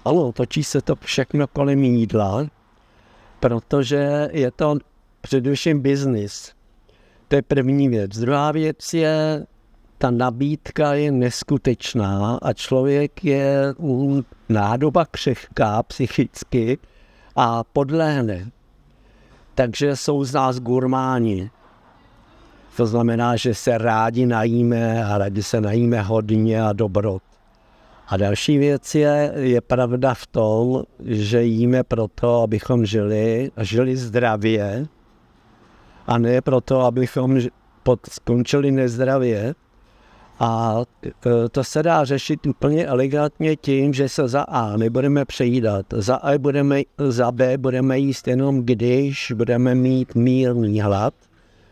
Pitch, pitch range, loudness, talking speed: 125 Hz, 115-140 Hz, -20 LUFS, 115 wpm